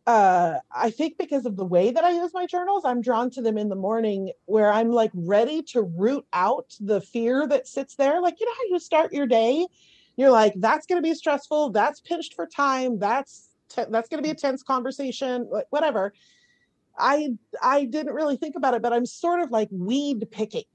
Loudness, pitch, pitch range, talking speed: -24 LUFS, 265 Hz, 225-310 Hz, 215 wpm